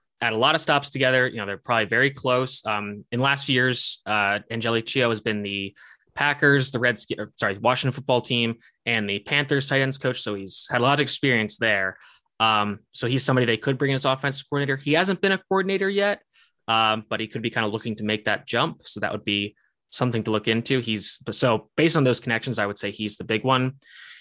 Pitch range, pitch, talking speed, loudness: 110-135 Hz, 125 Hz, 230 wpm, -23 LUFS